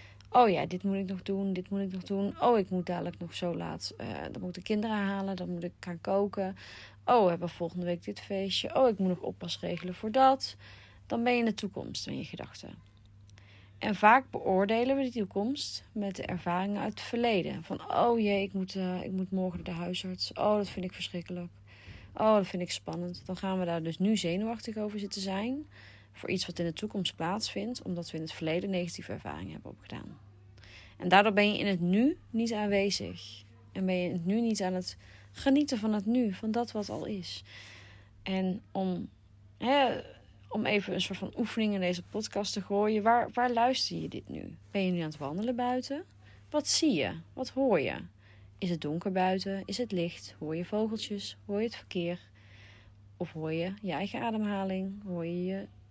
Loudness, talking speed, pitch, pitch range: -32 LUFS, 210 wpm, 185 Hz, 165-210 Hz